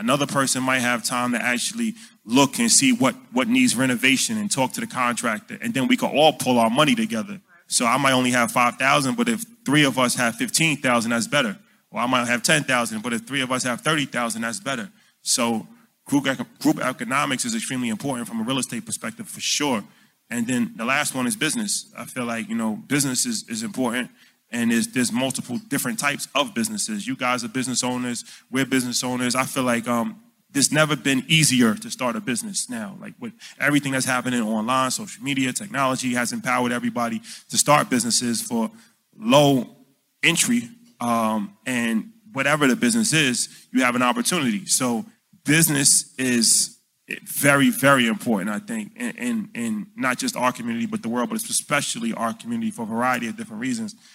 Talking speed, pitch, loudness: 190 wpm, 155 Hz, -21 LUFS